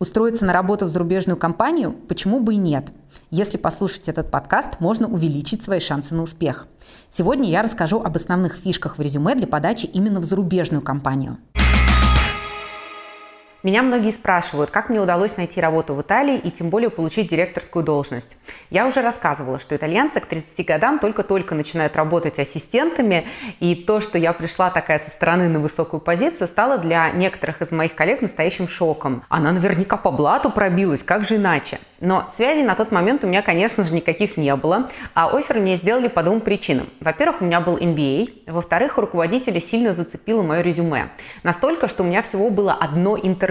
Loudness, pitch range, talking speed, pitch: -20 LUFS, 160-210 Hz, 175 wpm, 180 Hz